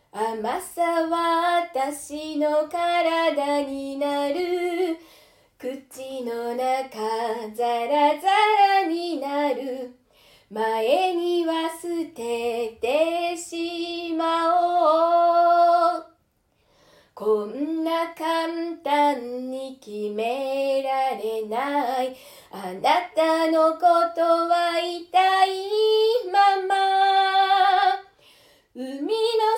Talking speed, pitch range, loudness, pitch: 115 characters per minute, 265-345 Hz, -23 LUFS, 325 Hz